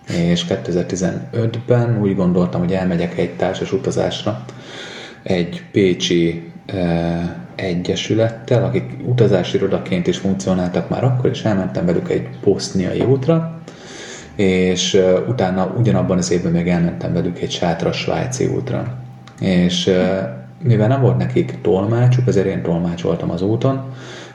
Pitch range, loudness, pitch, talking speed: 85-120 Hz, -18 LUFS, 95 Hz, 130 wpm